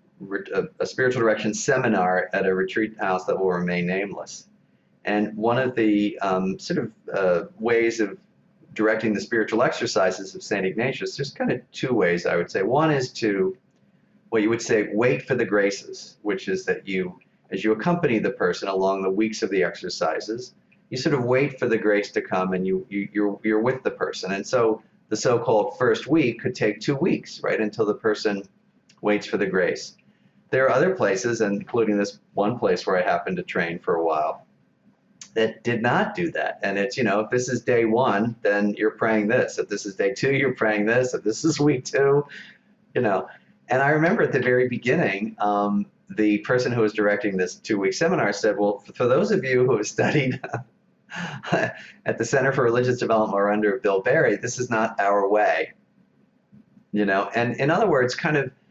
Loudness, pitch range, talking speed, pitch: -23 LUFS, 100-125 Hz, 200 wpm, 110 Hz